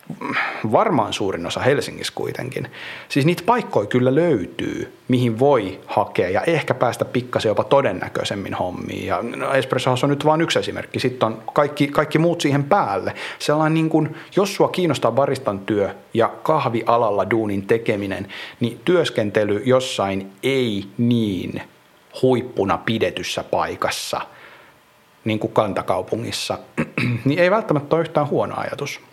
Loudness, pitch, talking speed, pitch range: -20 LUFS, 130 Hz, 130 wpm, 115-155 Hz